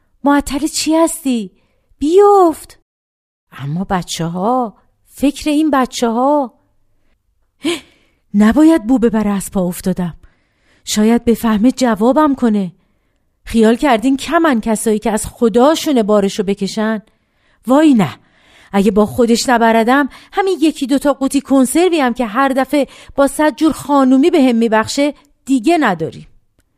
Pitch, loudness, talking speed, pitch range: 250 Hz, -14 LUFS, 125 wpm, 210-285 Hz